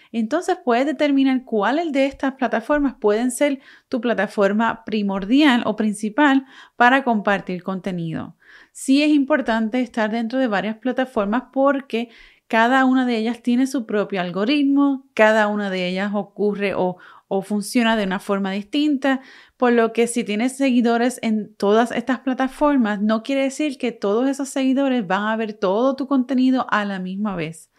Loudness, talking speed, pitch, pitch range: -20 LUFS, 160 wpm, 235 Hz, 210-270 Hz